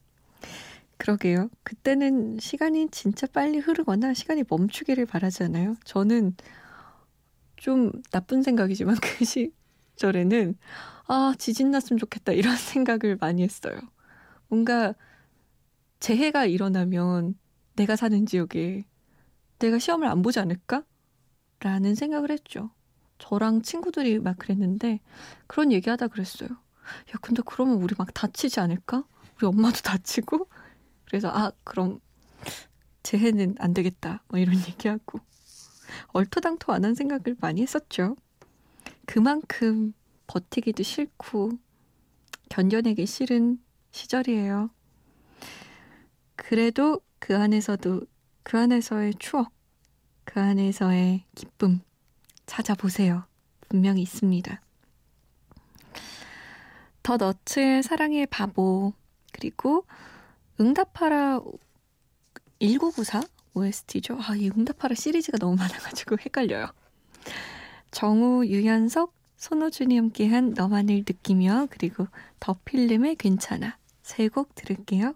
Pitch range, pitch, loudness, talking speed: 195-255 Hz, 220 Hz, -26 LUFS, 245 characters per minute